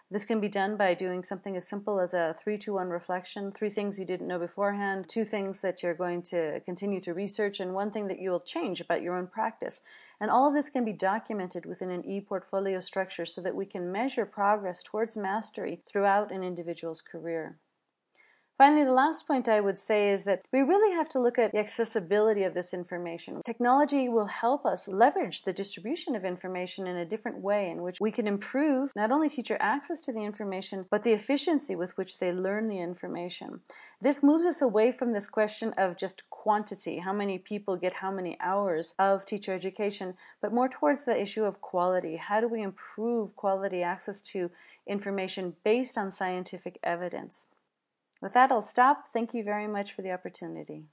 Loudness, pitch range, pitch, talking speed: -29 LUFS, 185-225 Hz, 200 Hz, 200 wpm